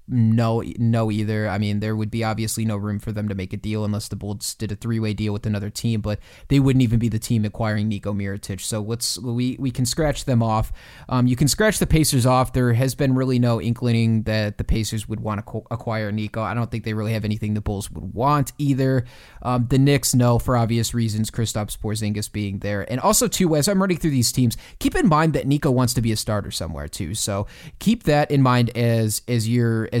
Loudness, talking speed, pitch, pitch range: -22 LUFS, 240 wpm, 115 Hz, 105-125 Hz